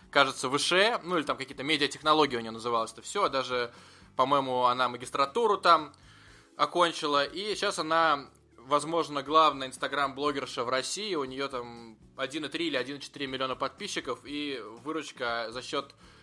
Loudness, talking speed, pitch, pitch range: -29 LUFS, 140 wpm, 140 Hz, 125-155 Hz